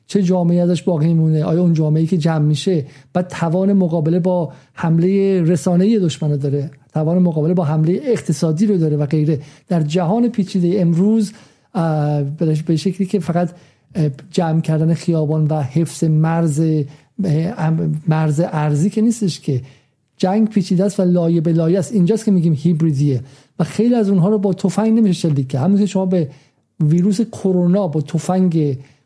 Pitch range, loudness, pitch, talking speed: 155-190 Hz, -17 LUFS, 170 Hz, 155 wpm